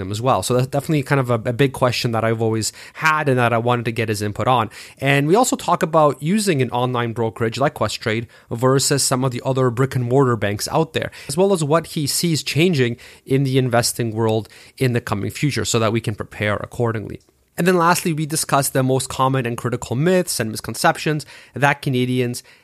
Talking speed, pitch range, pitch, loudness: 215 wpm, 115-145 Hz, 130 Hz, -19 LUFS